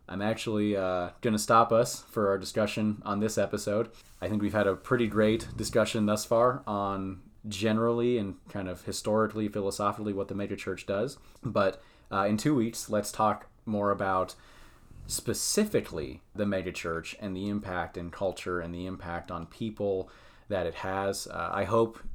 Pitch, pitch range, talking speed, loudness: 105 Hz, 95-110 Hz, 165 wpm, -30 LUFS